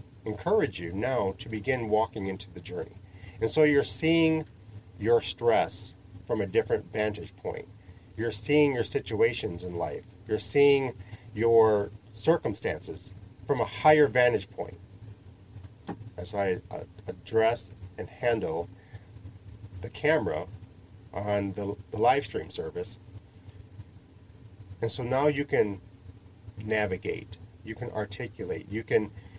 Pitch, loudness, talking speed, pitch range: 105 Hz, -28 LUFS, 125 wpm, 100-115 Hz